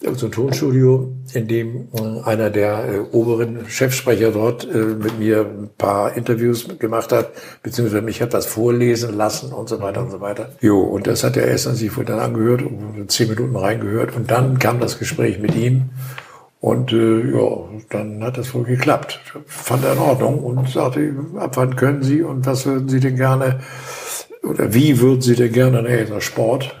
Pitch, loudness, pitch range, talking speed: 120 Hz, -18 LUFS, 110-130 Hz, 195 wpm